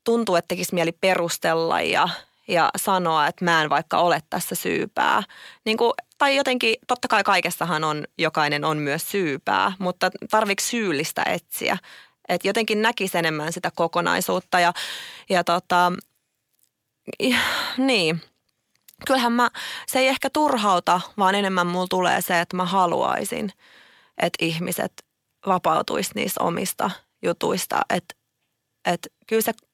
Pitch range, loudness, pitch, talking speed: 170-225 Hz, -22 LUFS, 185 Hz, 130 wpm